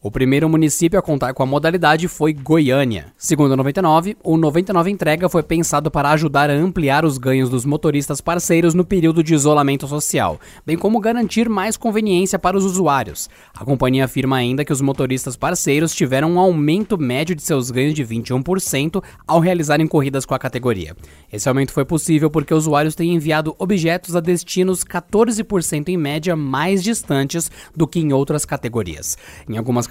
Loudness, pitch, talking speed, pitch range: -17 LUFS, 155 Hz, 175 wpm, 135-175 Hz